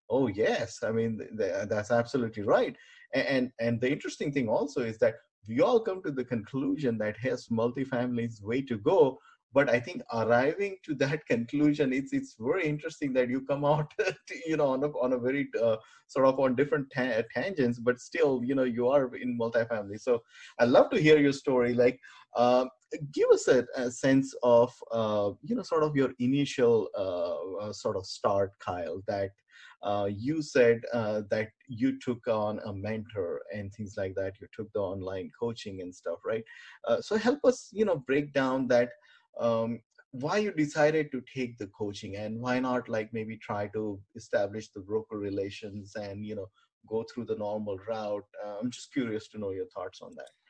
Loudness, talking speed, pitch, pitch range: -30 LUFS, 195 wpm, 125 Hz, 110-140 Hz